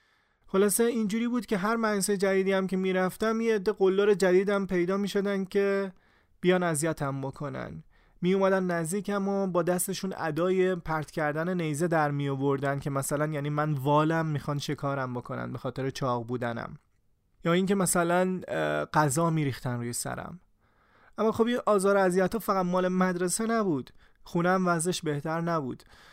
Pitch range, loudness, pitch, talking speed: 150-195 Hz, -28 LUFS, 180 Hz, 155 wpm